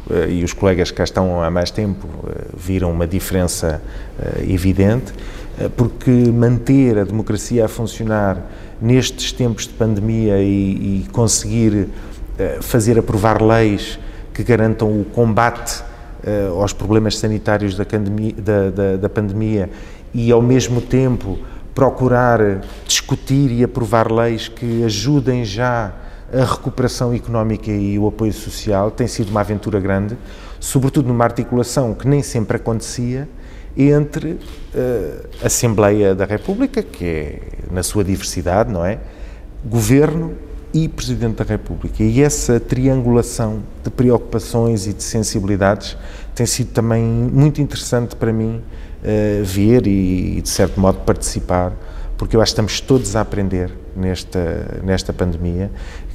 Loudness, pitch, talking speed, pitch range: -17 LUFS, 110 Hz, 140 wpm, 95-120 Hz